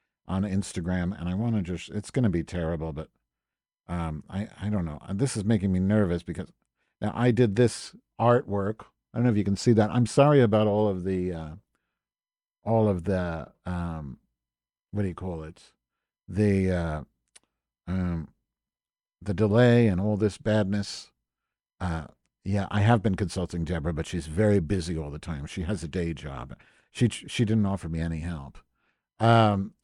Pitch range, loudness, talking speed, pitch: 85-105 Hz, -27 LUFS, 180 wpm, 95 Hz